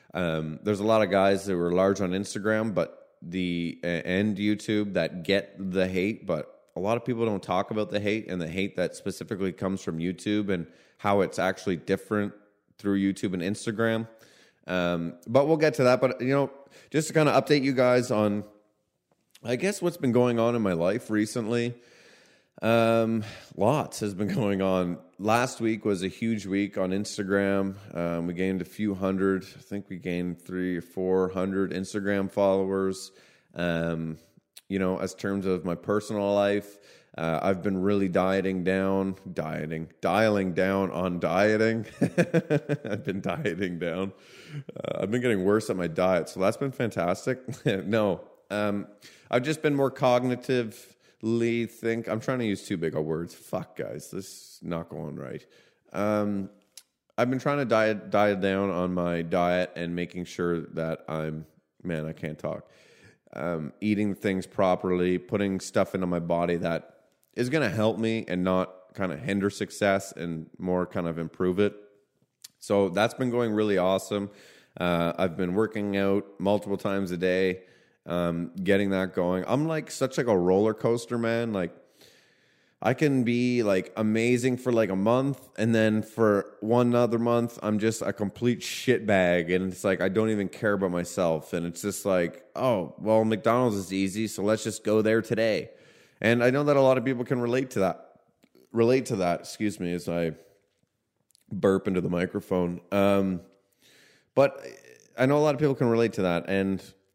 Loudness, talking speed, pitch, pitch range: -27 LUFS, 180 wpm, 100 Hz, 90-115 Hz